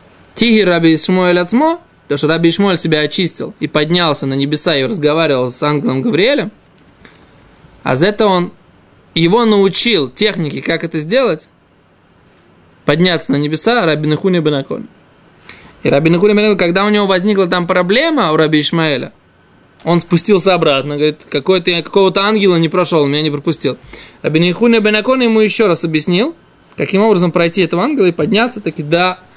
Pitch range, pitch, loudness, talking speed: 155-200 Hz, 175 Hz, -12 LUFS, 155 wpm